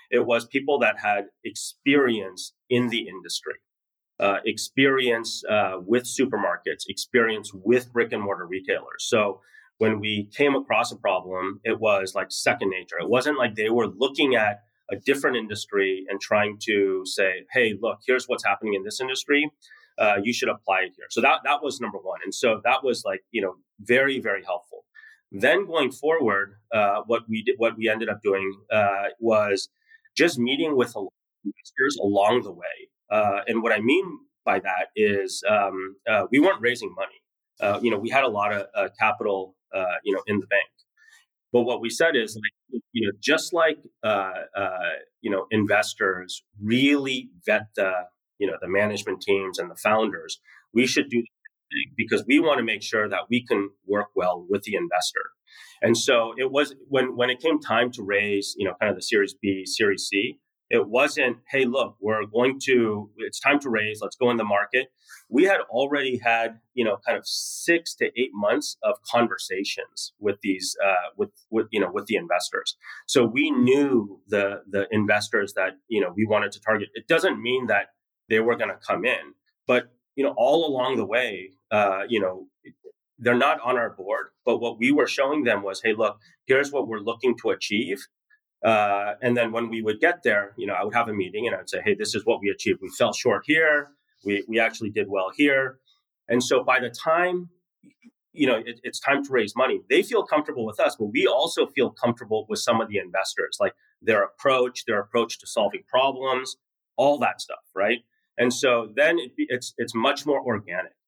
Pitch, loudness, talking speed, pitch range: 120 Hz, -24 LUFS, 200 wpm, 105-145 Hz